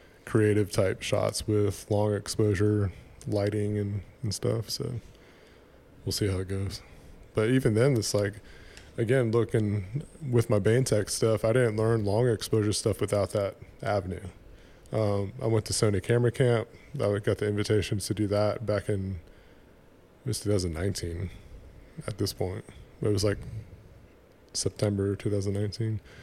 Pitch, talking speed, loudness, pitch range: 105 Hz, 145 wpm, -28 LUFS, 100-110 Hz